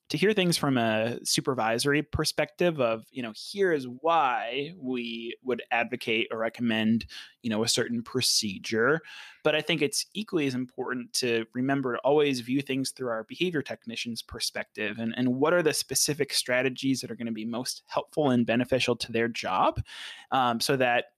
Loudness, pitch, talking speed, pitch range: -28 LUFS, 125 Hz, 180 wpm, 115-145 Hz